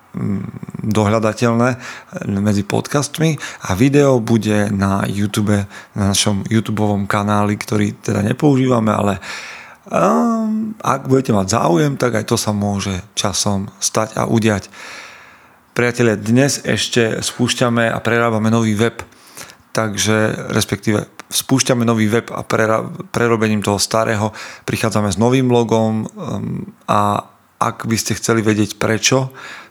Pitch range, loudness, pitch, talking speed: 105-120 Hz, -17 LUFS, 110 Hz, 120 wpm